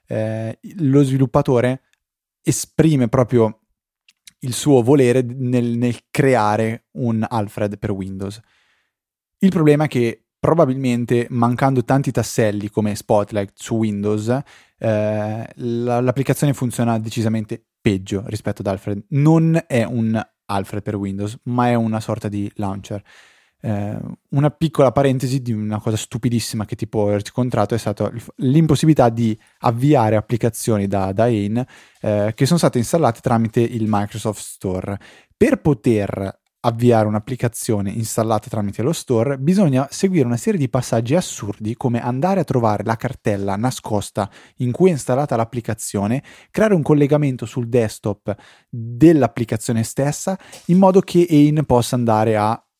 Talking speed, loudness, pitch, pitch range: 135 wpm, -19 LUFS, 120 Hz, 110-135 Hz